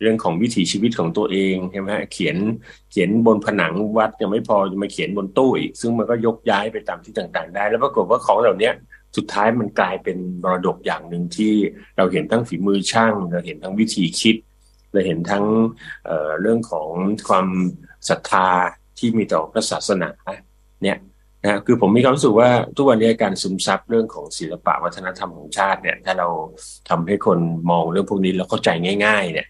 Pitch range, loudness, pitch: 90-115 Hz, -19 LUFS, 105 Hz